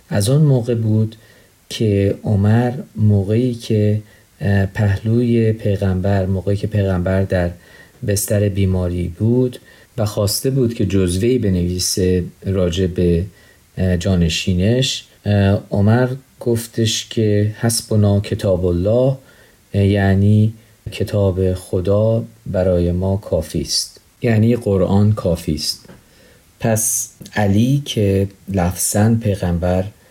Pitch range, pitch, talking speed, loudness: 95-115 Hz, 105 Hz, 95 wpm, -17 LUFS